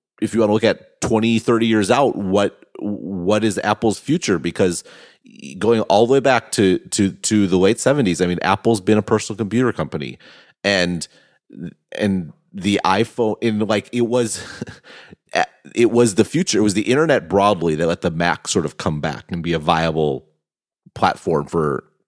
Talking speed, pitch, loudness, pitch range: 180 wpm, 105 Hz, -18 LUFS, 90-110 Hz